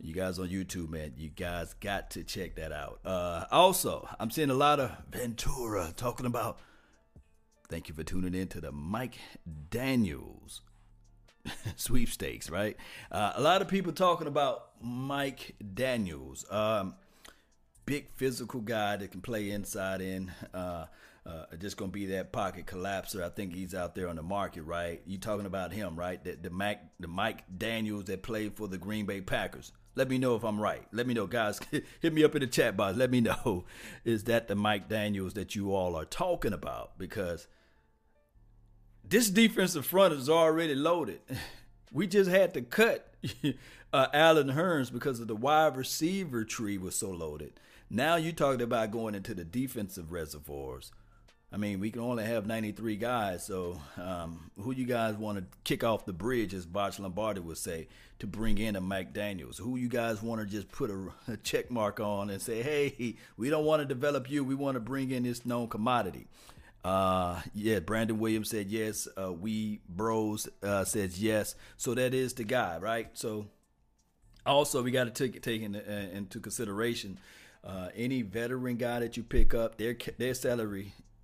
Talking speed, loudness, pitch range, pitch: 185 wpm, -32 LUFS, 95-125 Hz, 110 Hz